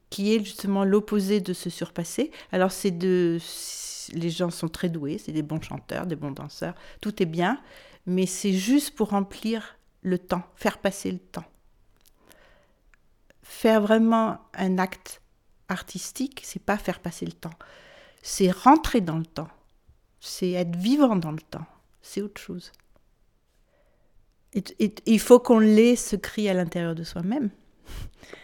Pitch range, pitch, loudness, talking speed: 175-220 Hz, 190 Hz, -25 LUFS, 155 wpm